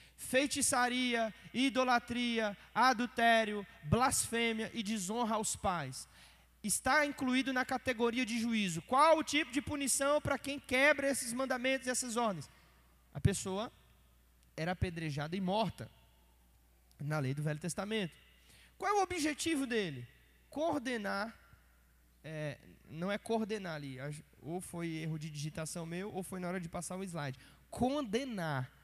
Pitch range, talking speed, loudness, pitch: 155-255 Hz, 135 wpm, -35 LUFS, 215 Hz